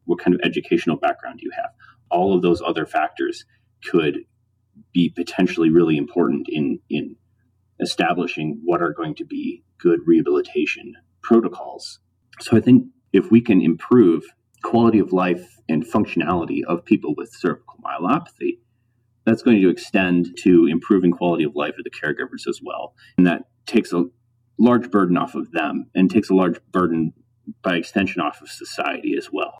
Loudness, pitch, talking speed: -20 LUFS, 120 Hz, 165 wpm